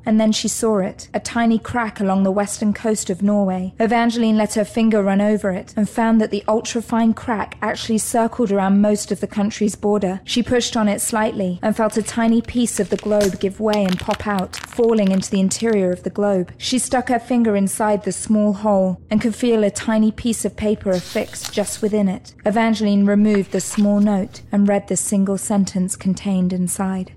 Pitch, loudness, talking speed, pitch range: 210 Hz, -19 LUFS, 205 wpm, 195-225 Hz